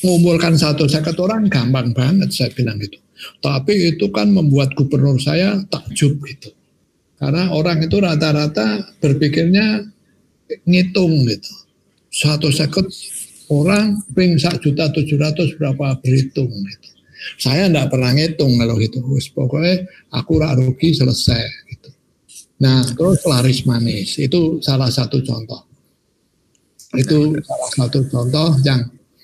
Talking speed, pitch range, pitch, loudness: 125 wpm, 130-170 Hz, 145 Hz, -16 LUFS